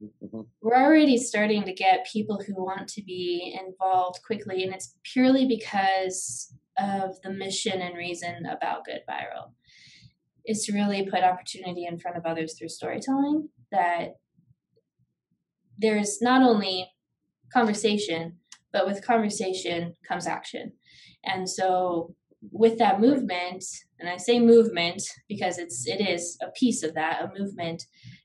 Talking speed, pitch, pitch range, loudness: 135 wpm, 190 Hz, 175-220 Hz, -26 LUFS